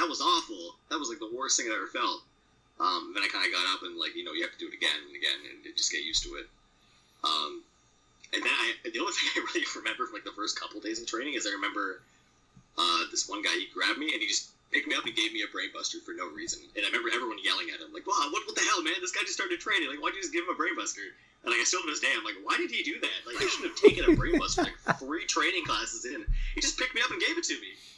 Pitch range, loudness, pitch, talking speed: 320-360 Hz, -30 LUFS, 340 Hz, 305 wpm